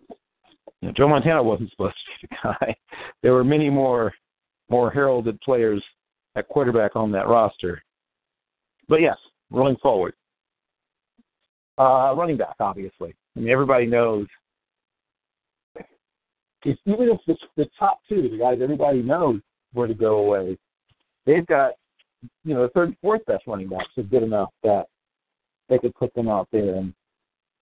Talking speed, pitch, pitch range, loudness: 150 wpm, 120 Hz, 105-145 Hz, -22 LUFS